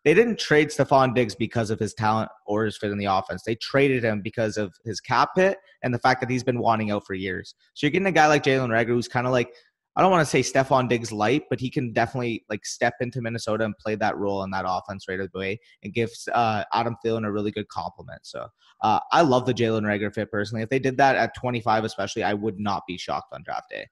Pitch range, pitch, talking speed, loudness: 105-125 Hz, 115 Hz, 260 wpm, -24 LUFS